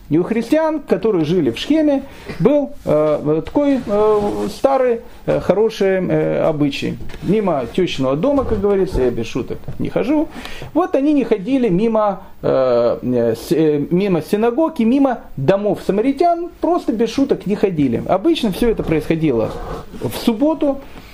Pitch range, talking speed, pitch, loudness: 165-275 Hz, 140 wpm, 215 Hz, -17 LUFS